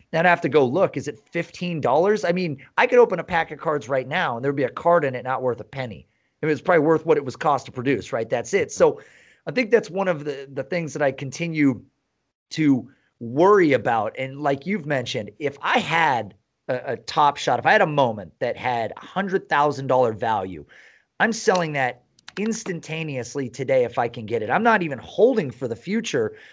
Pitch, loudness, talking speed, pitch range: 160 Hz, -22 LUFS, 225 wpm, 135-195 Hz